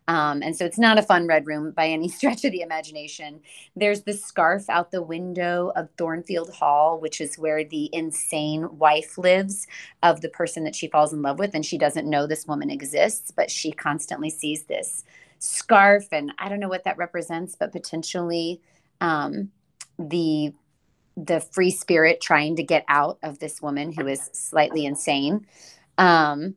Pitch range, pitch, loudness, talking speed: 150-175 Hz, 160 Hz, -23 LUFS, 180 wpm